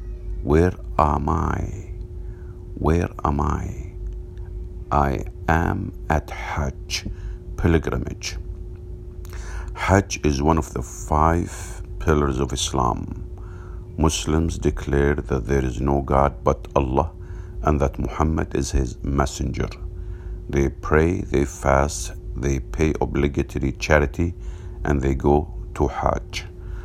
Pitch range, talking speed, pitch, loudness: 70-90 Hz, 105 wpm, 85 Hz, -23 LUFS